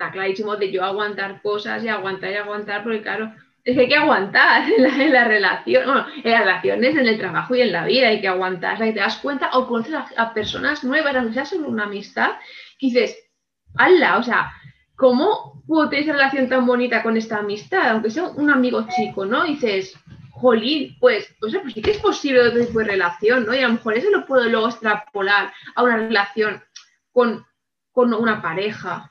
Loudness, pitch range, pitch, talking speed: -19 LUFS, 210-270 Hz, 230 Hz, 215 wpm